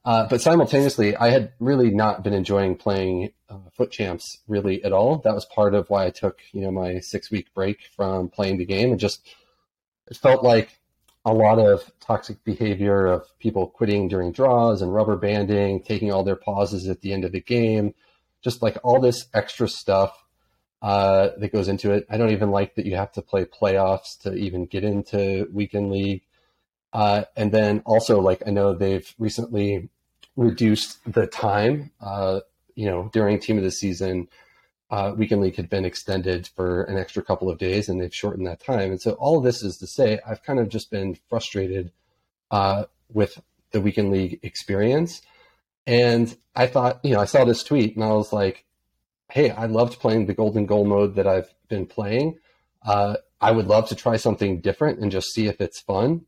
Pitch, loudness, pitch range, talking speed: 100 Hz, -22 LUFS, 95-110 Hz, 195 wpm